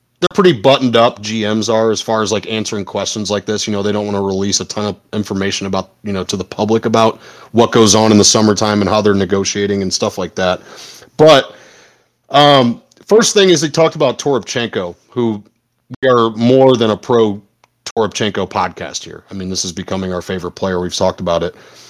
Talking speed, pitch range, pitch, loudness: 210 wpm, 100-115 Hz, 105 Hz, -14 LUFS